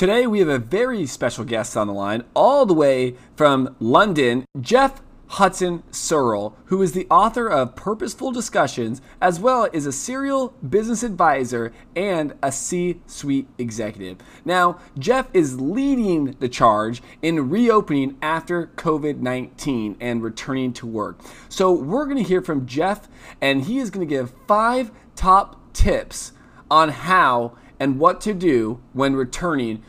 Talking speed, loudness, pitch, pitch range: 155 wpm, -20 LUFS, 150 Hz, 125-200 Hz